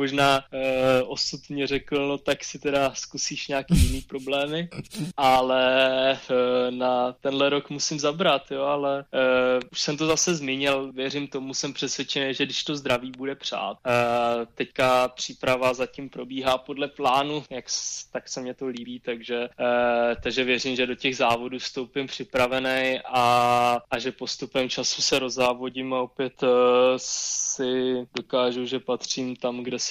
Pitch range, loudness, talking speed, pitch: 125-140 Hz, -25 LUFS, 155 wpm, 130 Hz